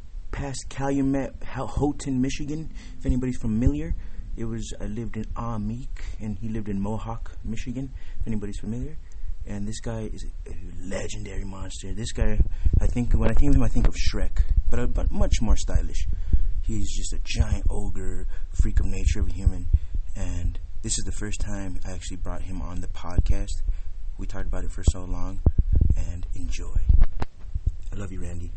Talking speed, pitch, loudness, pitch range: 180 wpm, 95 Hz, -29 LUFS, 85-110 Hz